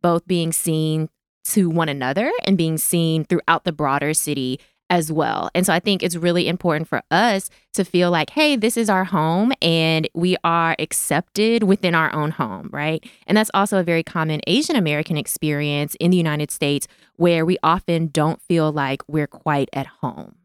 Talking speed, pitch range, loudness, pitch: 190 wpm, 155-180 Hz, -20 LUFS, 165 Hz